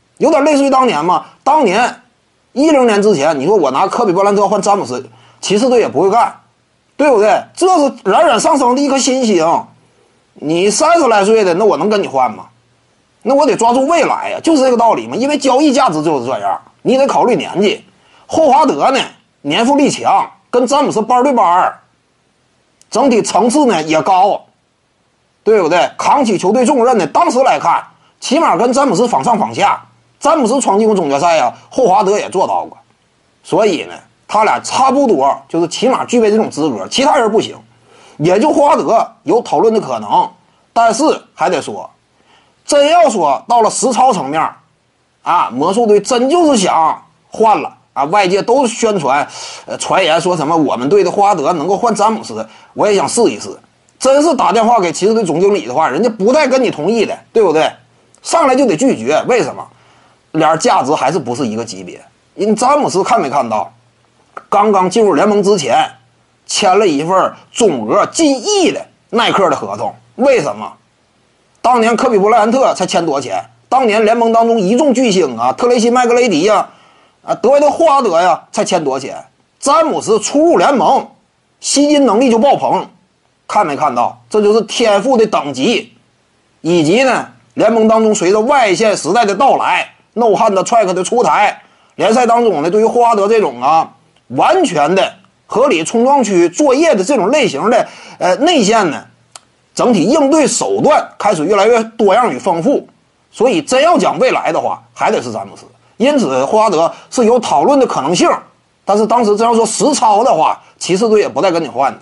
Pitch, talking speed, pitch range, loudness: 240 Hz, 280 characters per minute, 210-280 Hz, -12 LUFS